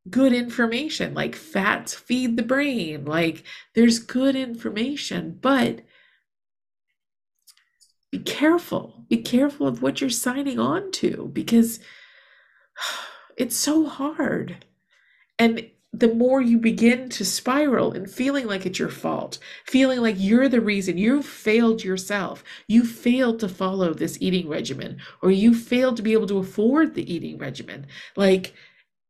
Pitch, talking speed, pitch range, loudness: 230 Hz, 135 wpm, 195-265 Hz, -22 LUFS